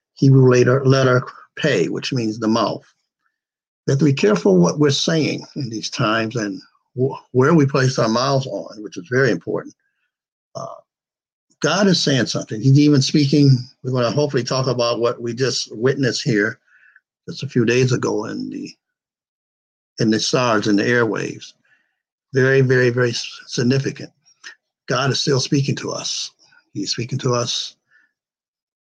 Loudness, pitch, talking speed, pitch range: -18 LUFS, 130 Hz, 160 wpm, 120-145 Hz